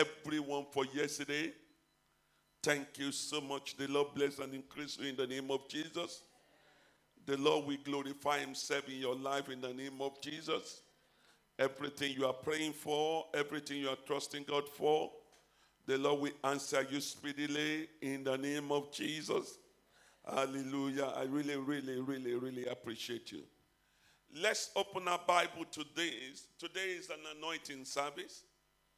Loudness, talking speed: -38 LUFS, 145 wpm